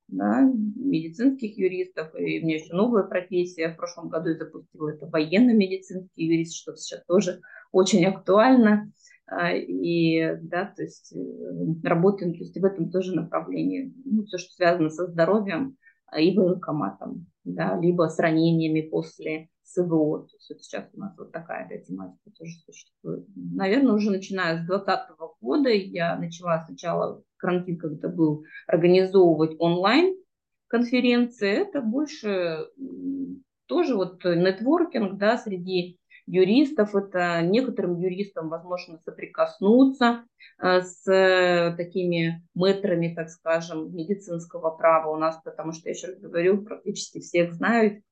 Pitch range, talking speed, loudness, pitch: 165-215 Hz, 130 wpm, -24 LUFS, 180 Hz